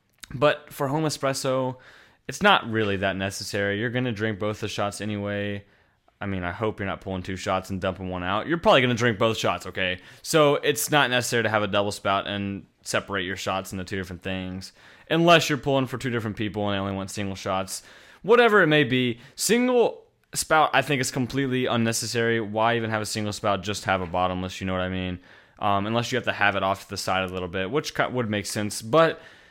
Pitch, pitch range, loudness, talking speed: 105 Hz, 95-125 Hz, -24 LUFS, 230 wpm